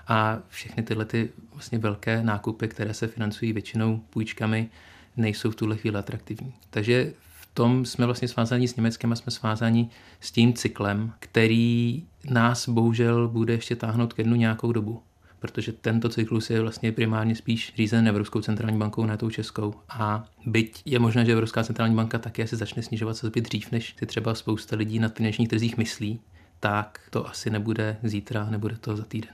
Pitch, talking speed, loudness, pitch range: 115 Hz, 180 wpm, -26 LUFS, 110-115 Hz